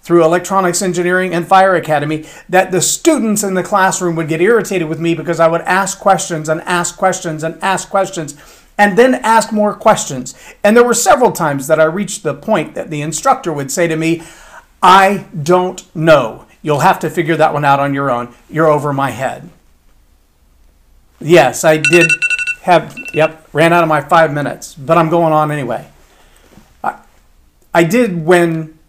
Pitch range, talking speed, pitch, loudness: 155-190 Hz, 180 wpm, 165 Hz, -13 LUFS